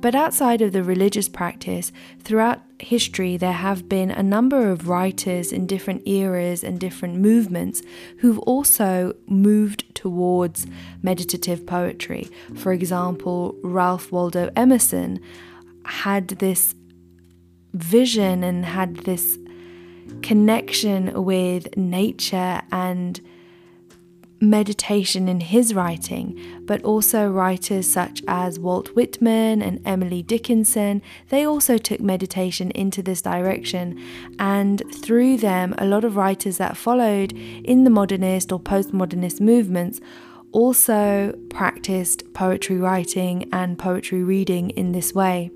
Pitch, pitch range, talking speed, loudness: 185 Hz, 180-205 Hz, 115 wpm, -20 LUFS